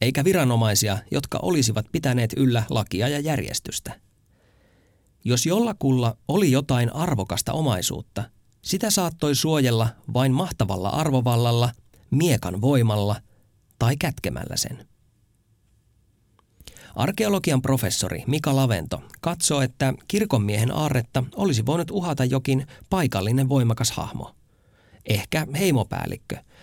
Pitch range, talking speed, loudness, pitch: 110-140 Hz, 95 wpm, -23 LUFS, 125 Hz